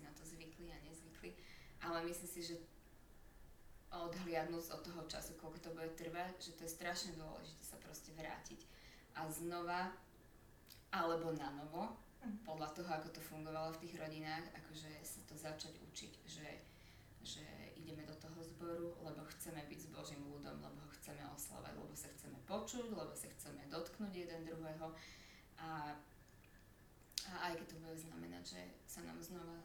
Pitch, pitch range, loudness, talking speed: 160 Hz, 150-170 Hz, -49 LUFS, 160 wpm